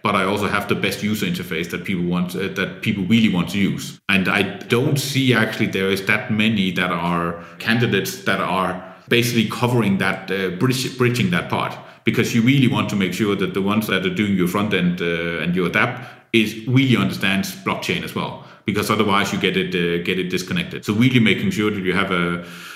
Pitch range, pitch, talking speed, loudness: 95-115 Hz, 100 Hz, 220 wpm, -20 LUFS